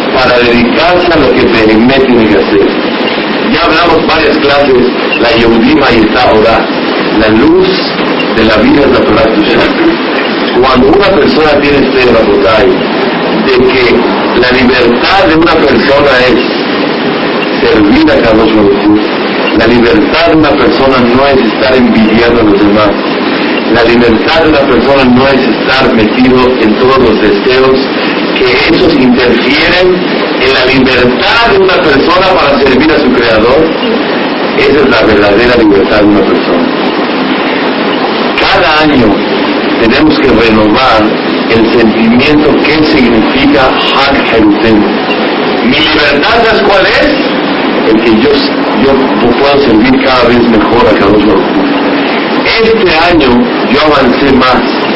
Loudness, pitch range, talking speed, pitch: -6 LUFS, 110-130 Hz, 135 wpm, 125 Hz